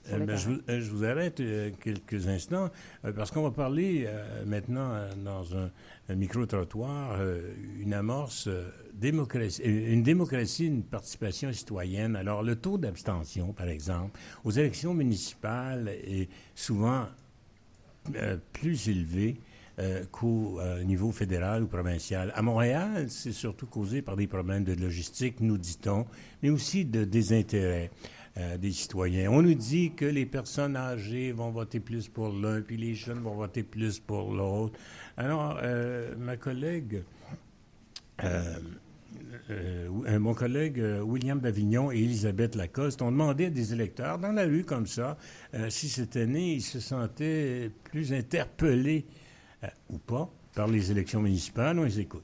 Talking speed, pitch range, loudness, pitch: 155 wpm, 100-130 Hz, -31 LUFS, 115 Hz